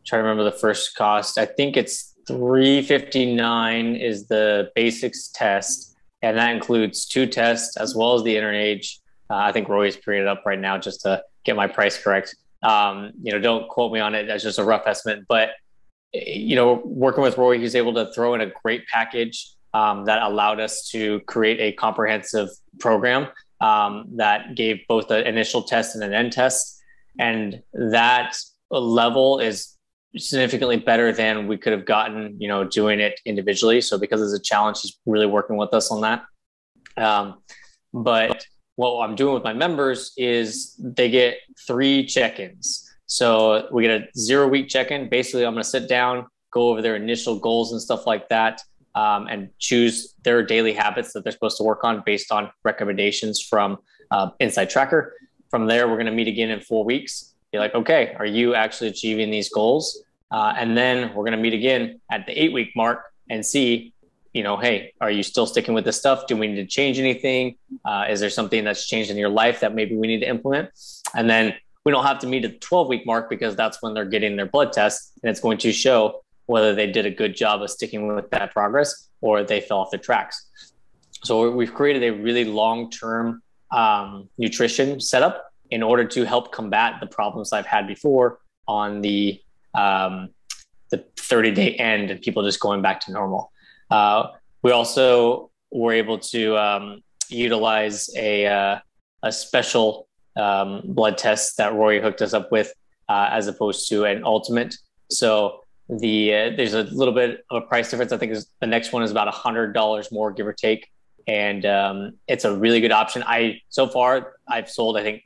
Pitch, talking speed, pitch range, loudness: 115 Hz, 200 wpm, 105-125 Hz, -21 LUFS